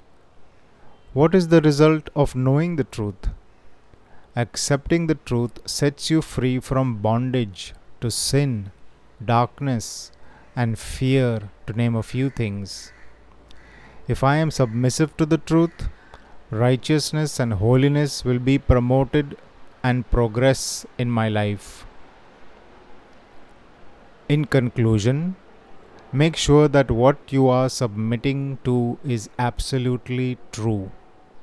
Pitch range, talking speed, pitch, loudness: 115-140 Hz, 110 wpm, 125 Hz, -21 LUFS